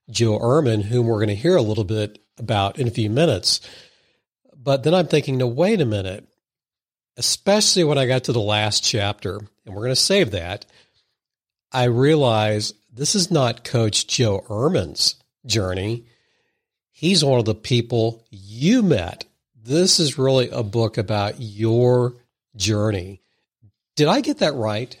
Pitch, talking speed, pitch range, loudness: 120 Hz, 160 wpm, 110-145 Hz, -20 LUFS